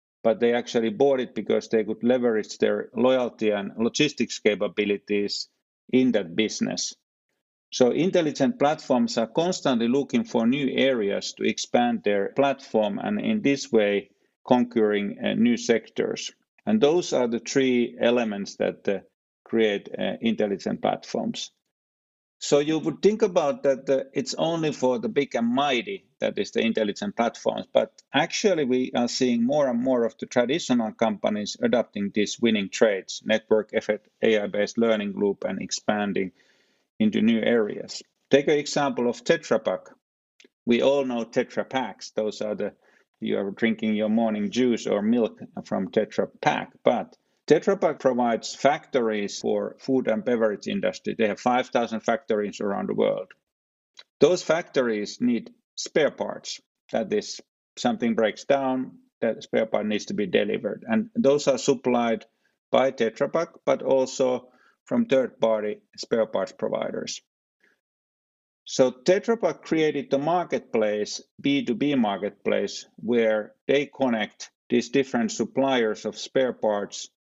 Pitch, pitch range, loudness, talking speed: 120 Hz, 110-140 Hz, -25 LUFS, 145 wpm